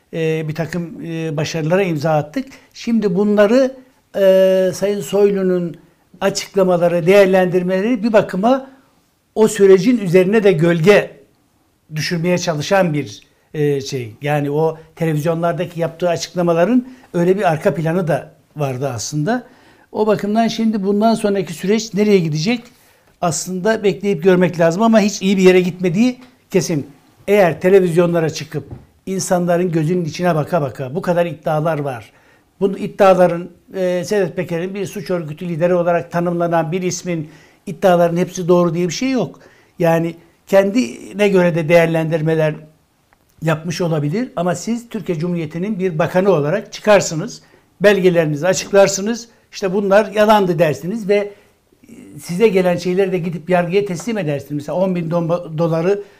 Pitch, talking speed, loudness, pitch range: 180 Hz, 130 wpm, -16 LUFS, 165-200 Hz